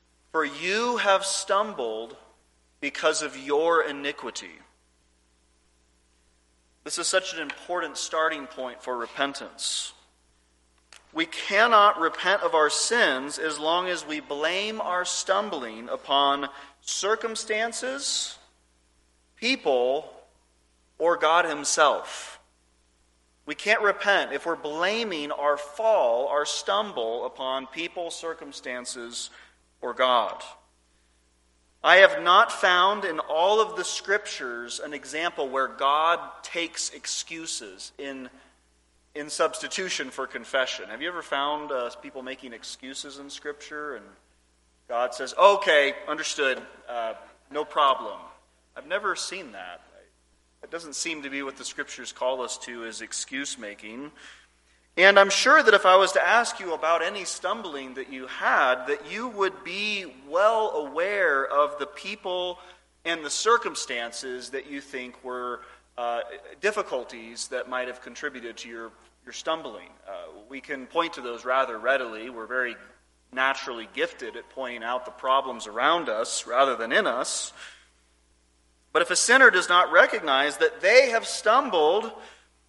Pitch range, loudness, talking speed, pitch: 110-170 Hz, -25 LUFS, 130 wpm, 140 Hz